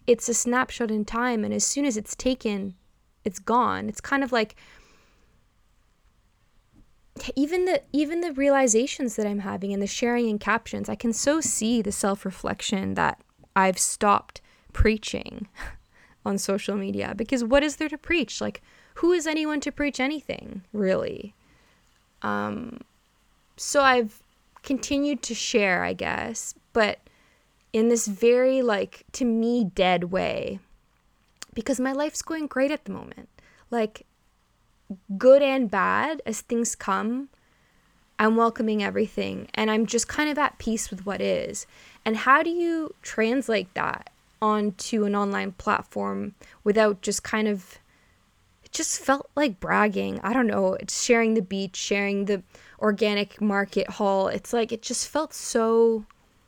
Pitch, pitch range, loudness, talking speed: 230 Hz, 205-265 Hz, -25 LUFS, 150 wpm